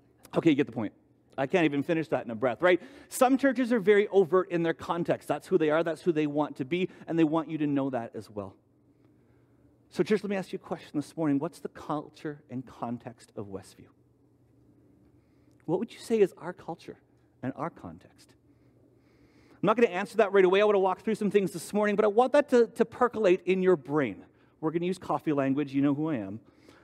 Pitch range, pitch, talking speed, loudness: 145-205 Hz, 170 Hz, 235 wpm, -28 LUFS